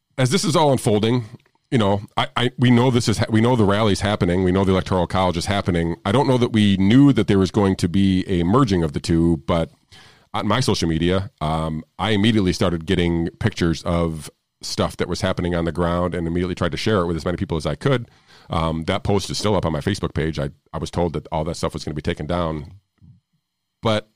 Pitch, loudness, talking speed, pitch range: 95 Hz, -20 LUFS, 250 wpm, 85-110 Hz